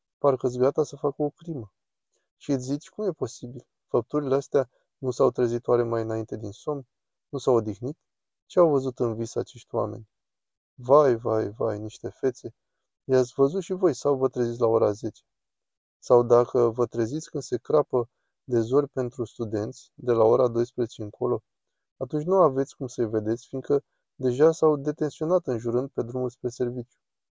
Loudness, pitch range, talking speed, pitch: -26 LUFS, 120-140 Hz, 170 wpm, 125 Hz